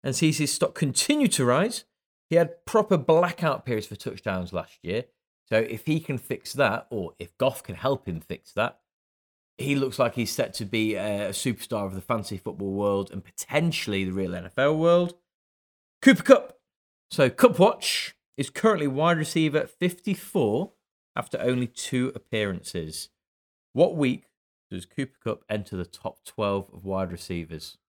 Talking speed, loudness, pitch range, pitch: 165 wpm, -26 LUFS, 95-155 Hz, 120 Hz